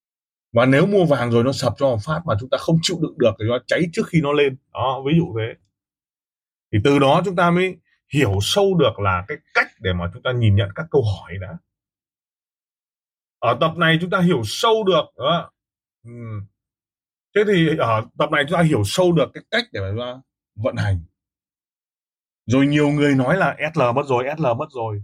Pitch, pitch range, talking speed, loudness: 135 Hz, 110-160 Hz, 210 wpm, -19 LUFS